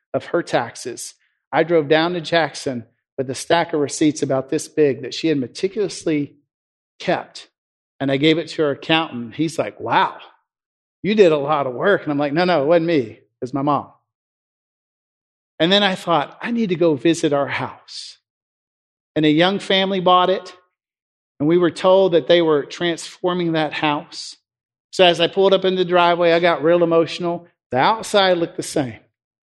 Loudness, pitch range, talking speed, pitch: -18 LUFS, 145-180 Hz, 190 wpm, 165 Hz